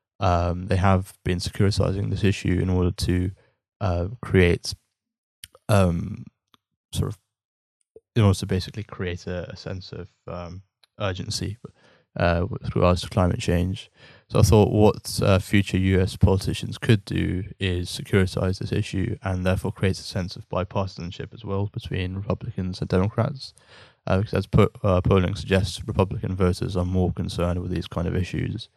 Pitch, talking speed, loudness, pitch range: 95 Hz, 155 wpm, -24 LUFS, 90-105 Hz